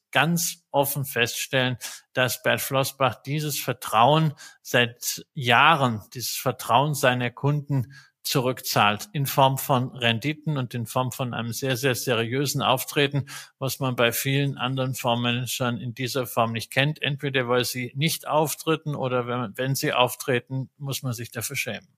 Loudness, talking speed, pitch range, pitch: -24 LUFS, 145 wpm, 120-140 Hz, 130 Hz